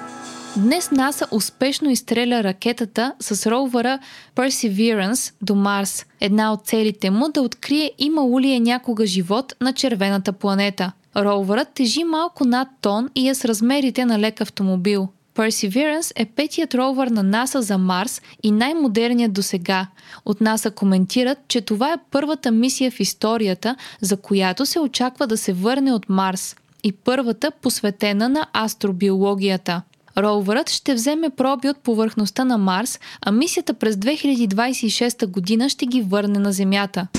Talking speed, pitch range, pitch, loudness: 145 wpm, 200-260 Hz, 230 Hz, -20 LUFS